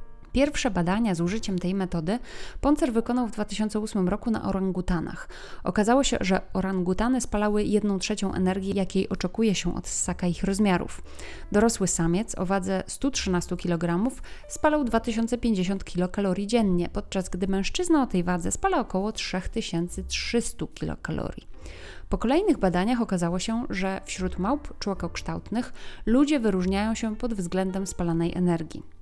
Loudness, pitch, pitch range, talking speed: -26 LUFS, 195 Hz, 185-230 Hz, 130 wpm